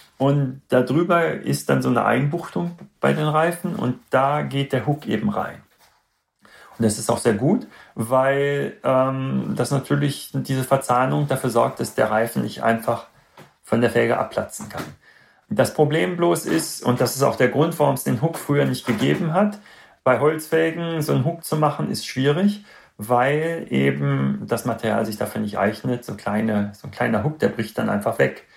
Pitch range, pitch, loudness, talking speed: 120-155 Hz, 135 Hz, -21 LUFS, 185 wpm